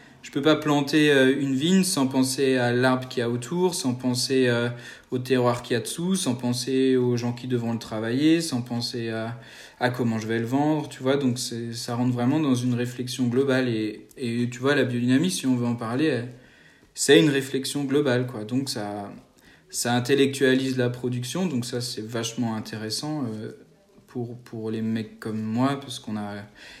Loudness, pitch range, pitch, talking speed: -24 LUFS, 120-135 Hz, 125 Hz, 195 wpm